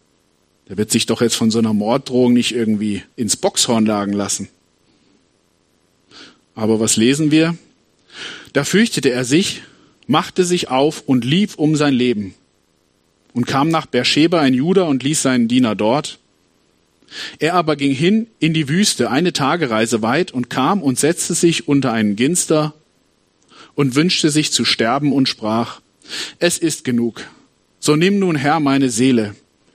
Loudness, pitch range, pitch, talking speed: -16 LUFS, 115-160 Hz, 135 Hz, 155 wpm